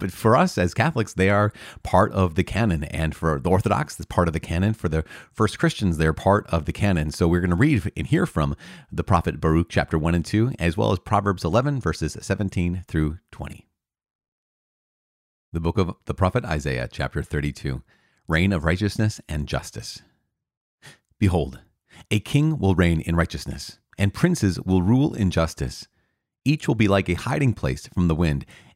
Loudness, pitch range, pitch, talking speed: -23 LUFS, 80-105 Hz, 90 Hz, 185 wpm